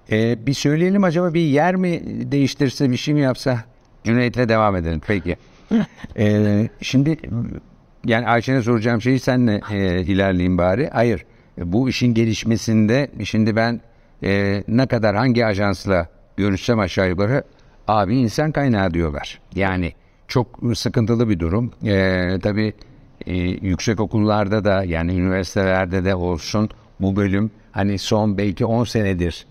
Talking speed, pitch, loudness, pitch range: 135 wpm, 110 Hz, -19 LUFS, 95-125 Hz